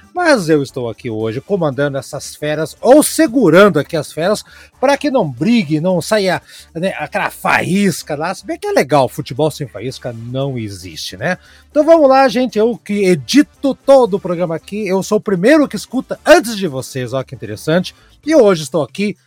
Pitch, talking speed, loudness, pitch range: 185 Hz, 190 wpm, -14 LUFS, 145-235 Hz